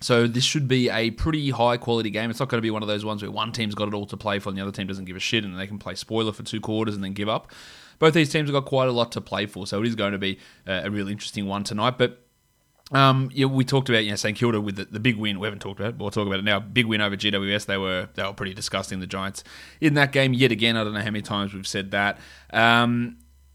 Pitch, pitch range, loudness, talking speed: 105 Hz, 100-120 Hz, -24 LUFS, 310 wpm